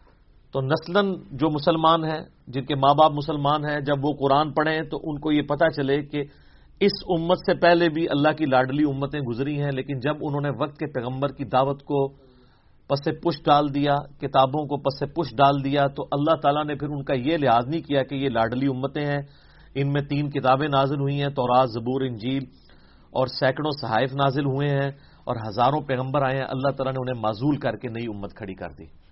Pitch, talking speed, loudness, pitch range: 140 Hz, 215 wpm, -24 LUFS, 130-150 Hz